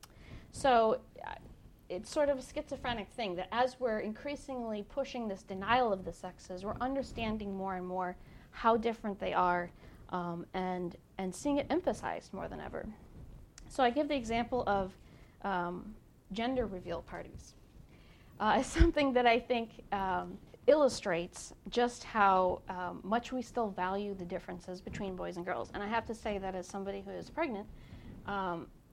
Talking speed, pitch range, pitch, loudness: 165 wpm, 185-245 Hz, 205 Hz, -35 LUFS